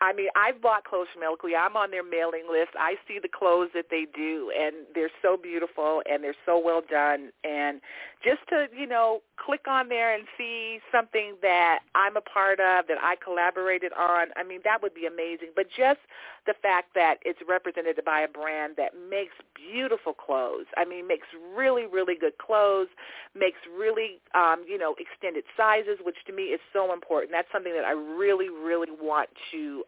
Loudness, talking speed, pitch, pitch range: -27 LUFS, 195 wpm, 185 Hz, 165-220 Hz